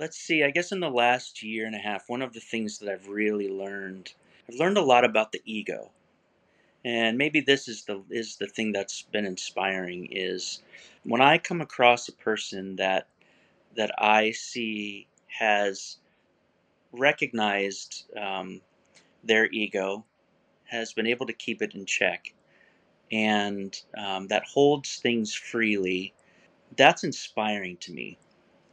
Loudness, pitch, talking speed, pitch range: -26 LUFS, 110 Hz, 150 wpm, 100-120 Hz